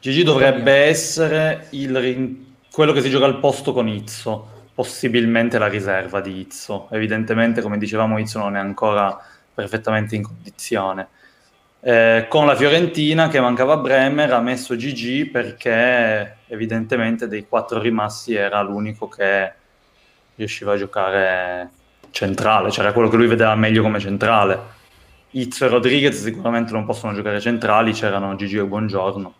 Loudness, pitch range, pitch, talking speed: -18 LUFS, 105-130 Hz, 110 Hz, 145 wpm